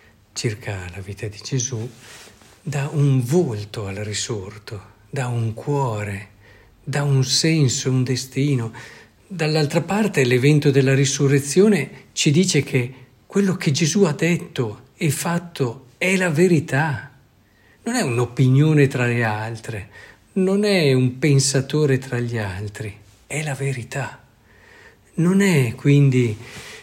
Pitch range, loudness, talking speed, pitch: 115-150 Hz, -20 LUFS, 125 wpm, 135 Hz